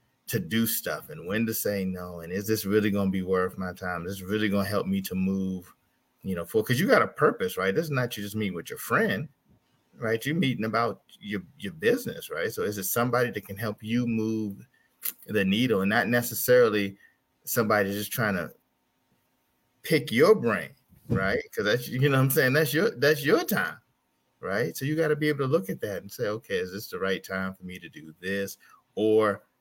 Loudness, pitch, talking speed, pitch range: -27 LUFS, 110 Hz, 225 wpm, 95-125 Hz